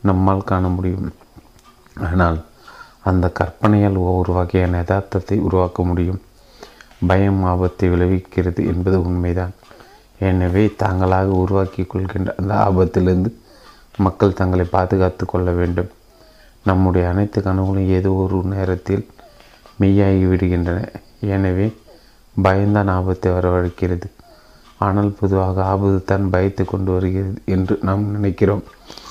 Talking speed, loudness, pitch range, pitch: 100 wpm, -18 LUFS, 90-100 Hz, 95 Hz